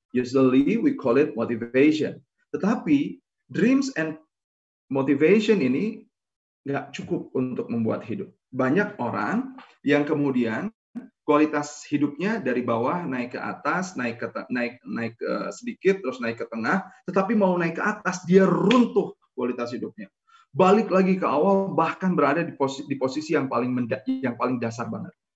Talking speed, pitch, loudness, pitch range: 150 wpm, 155 Hz, -24 LUFS, 130-195 Hz